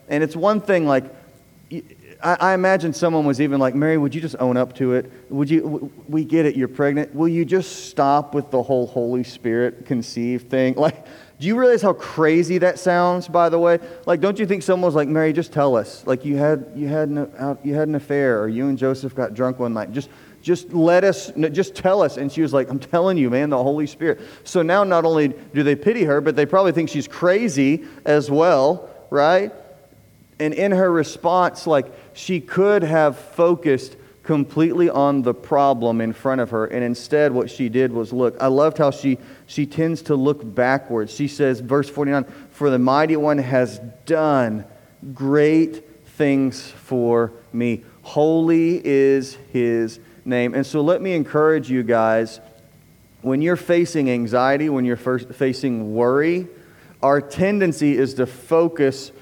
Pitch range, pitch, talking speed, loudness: 130-165 Hz, 145 Hz, 185 wpm, -19 LUFS